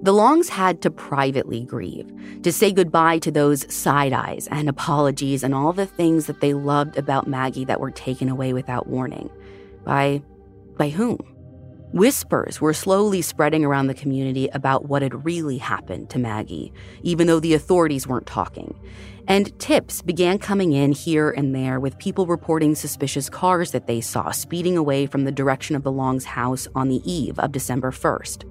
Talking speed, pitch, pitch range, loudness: 175 wpm, 140 Hz, 130-165 Hz, -21 LUFS